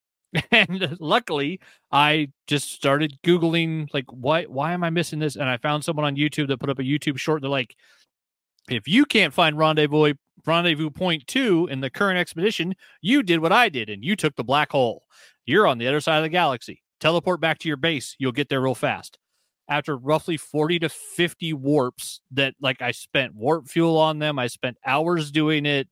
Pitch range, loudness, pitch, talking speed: 140-165 Hz, -22 LUFS, 155 Hz, 200 wpm